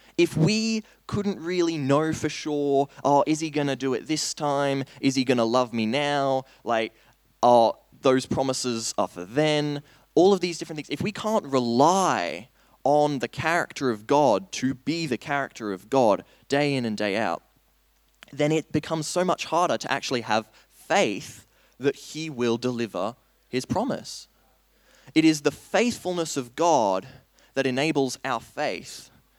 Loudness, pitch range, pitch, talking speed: -25 LUFS, 125-155 Hz, 140 Hz, 165 wpm